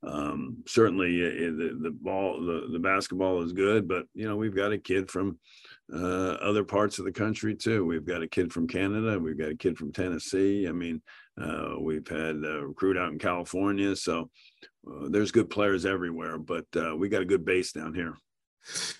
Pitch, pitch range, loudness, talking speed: 95 Hz, 85-100 Hz, -29 LUFS, 200 wpm